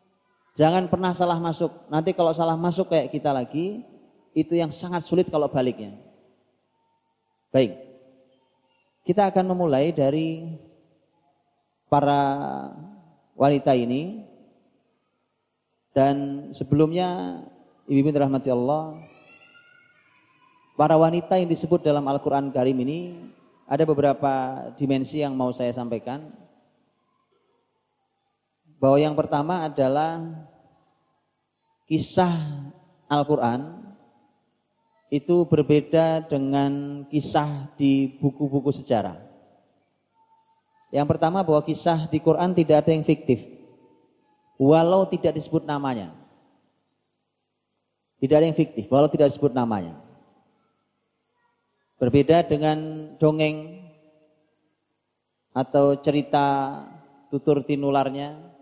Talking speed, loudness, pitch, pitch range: 90 wpm, -23 LUFS, 150 Hz, 140-165 Hz